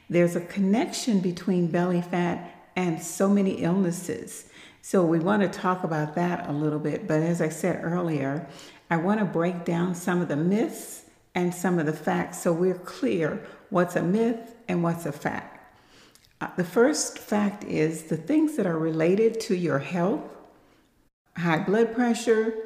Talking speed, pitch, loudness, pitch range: 170 wpm, 180 Hz, -26 LUFS, 170-200 Hz